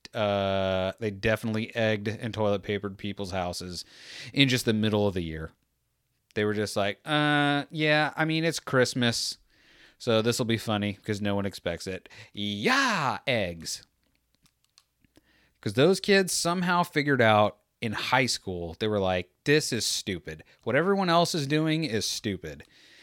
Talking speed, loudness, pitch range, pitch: 155 wpm, -27 LUFS, 100-135 Hz, 110 Hz